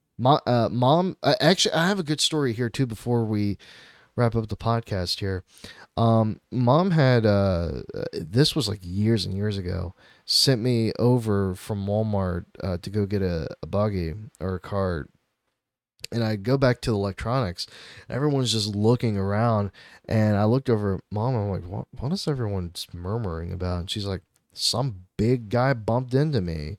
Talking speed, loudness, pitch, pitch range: 180 wpm, -24 LUFS, 110 Hz, 95-125 Hz